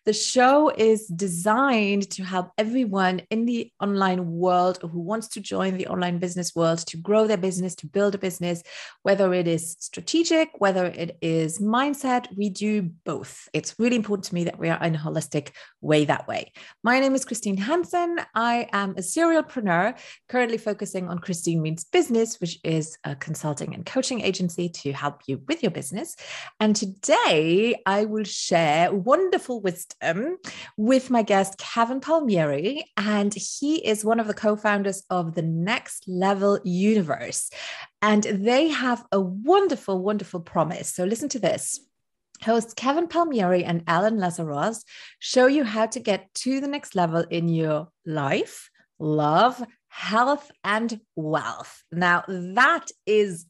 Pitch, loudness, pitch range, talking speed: 200 Hz, -24 LUFS, 175-235 Hz, 160 wpm